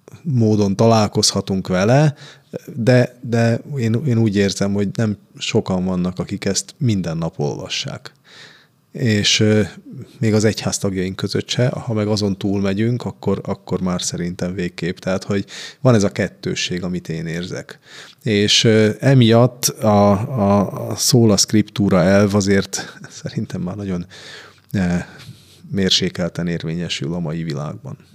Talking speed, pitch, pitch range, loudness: 130 wpm, 105 Hz, 95-115 Hz, -18 LUFS